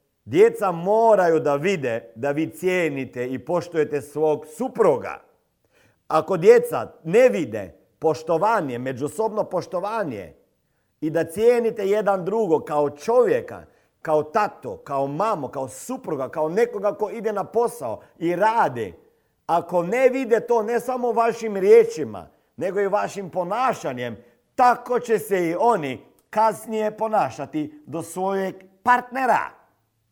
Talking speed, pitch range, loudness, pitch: 120 wpm, 155-230 Hz, -22 LUFS, 195 Hz